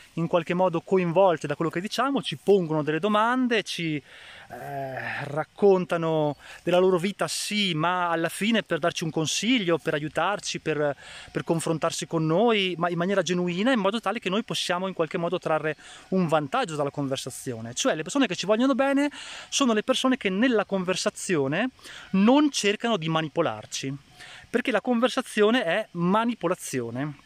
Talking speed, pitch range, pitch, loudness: 160 wpm, 160-210 Hz, 175 Hz, -25 LUFS